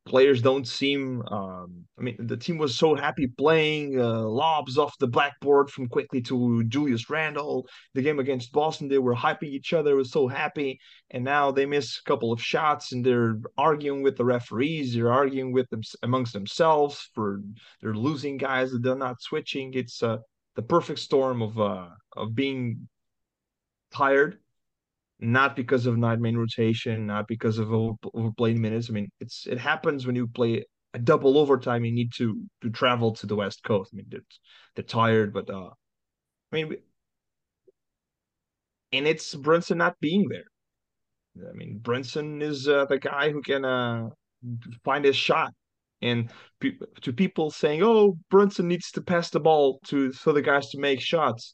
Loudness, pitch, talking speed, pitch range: -25 LUFS, 130 Hz, 175 wpm, 115-145 Hz